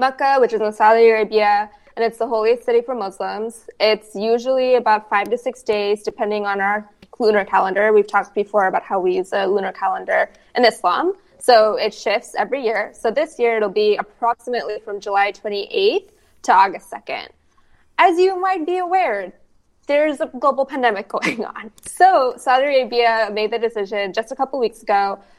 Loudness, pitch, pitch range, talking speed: -18 LUFS, 225 Hz, 205-260 Hz, 180 wpm